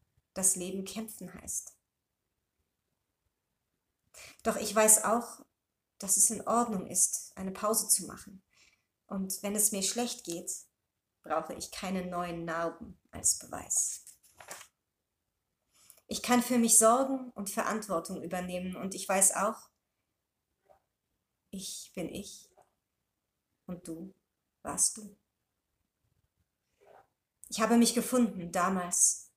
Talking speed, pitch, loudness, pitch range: 110 wpm, 195 Hz, -29 LUFS, 180-225 Hz